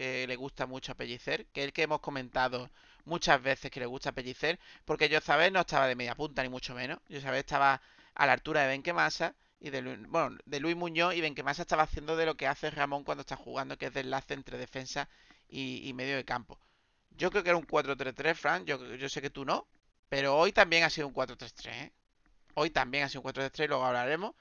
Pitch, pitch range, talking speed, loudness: 140 Hz, 130-155 Hz, 230 wpm, -32 LUFS